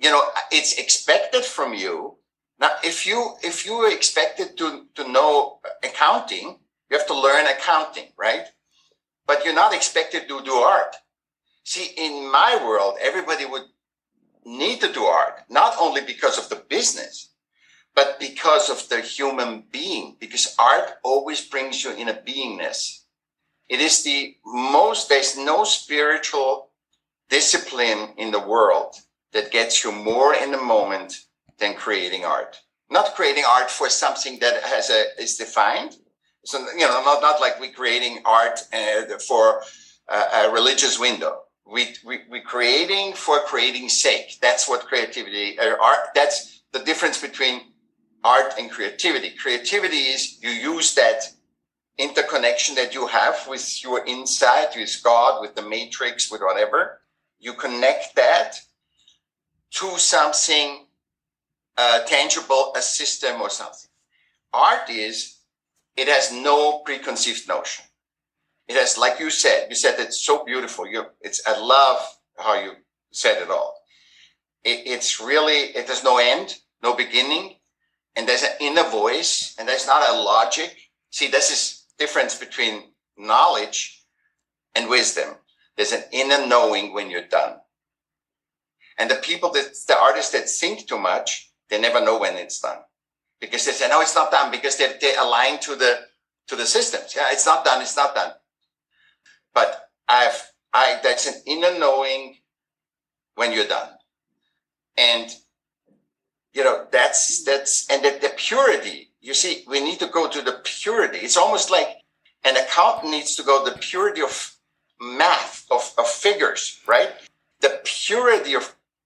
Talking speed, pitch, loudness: 150 wpm, 160 Hz, -20 LUFS